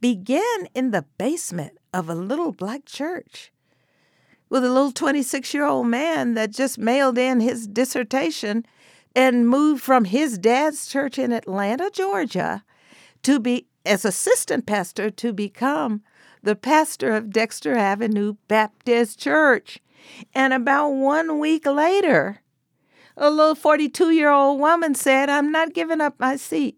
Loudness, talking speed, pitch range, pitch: -21 LUFS, 145 wpm, 225-295 Hz, 265 Hz